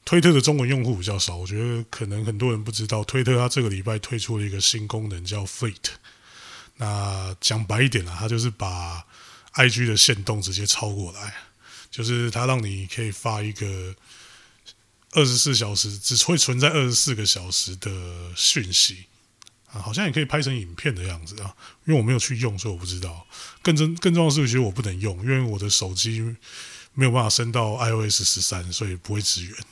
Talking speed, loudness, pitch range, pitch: 310 characters per minute, -22 LUFS, 100-125 Hz, 110 Hz